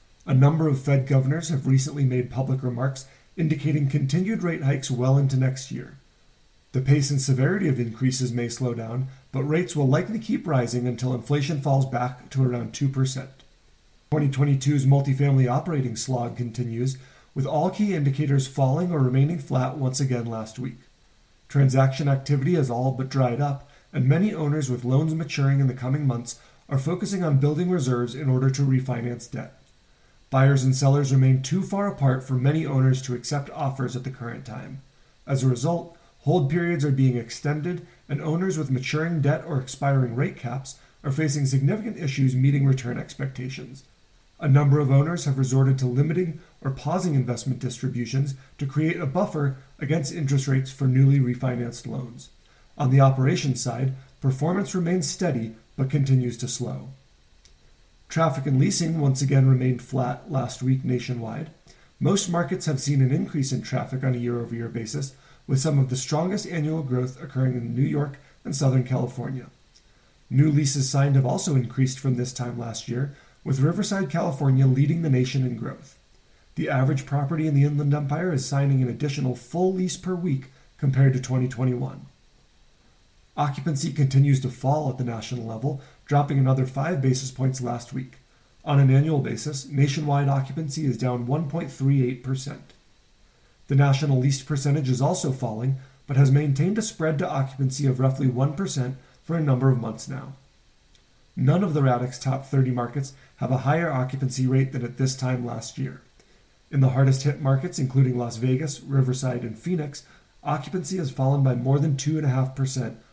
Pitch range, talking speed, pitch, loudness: 130-145 Hz, 170 wpm, 135 Hz, -24 LUFS